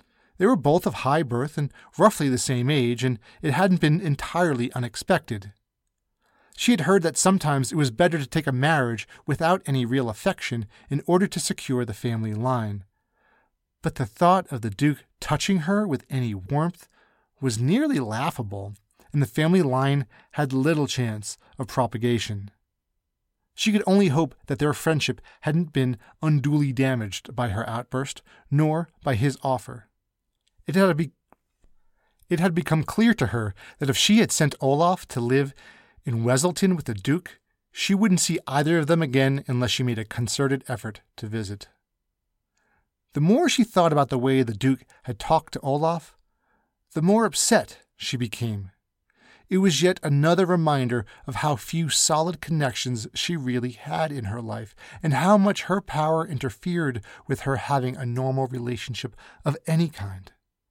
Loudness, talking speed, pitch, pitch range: -24 LUFS, 160 wpm, 135 Hz, 120-165 Hz